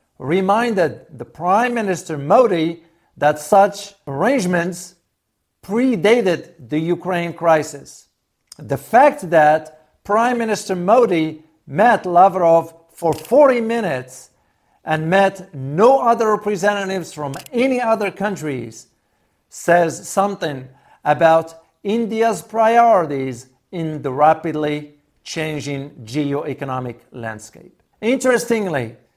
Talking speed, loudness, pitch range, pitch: 90 wpm, -17 LUFS, 145-205 Hz, 165 Hz